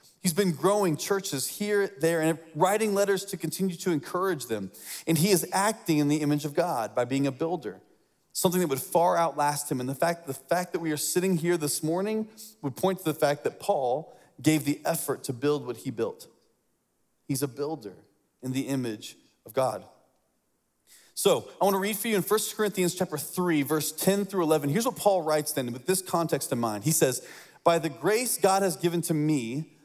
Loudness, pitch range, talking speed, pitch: -27 LUFS, 145-190 Hz, 210 wpm, 165 Hz